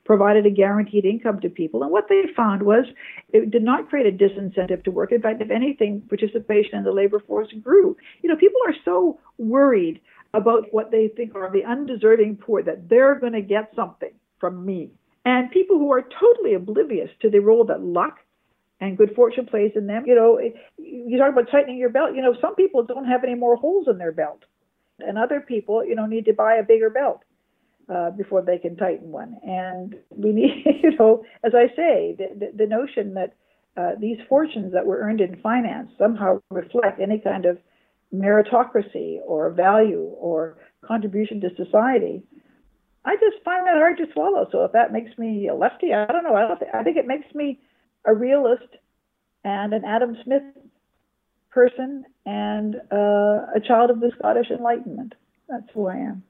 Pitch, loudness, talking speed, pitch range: 230 Hz, -20 LUFS, 195 wpm, 210-275 Hz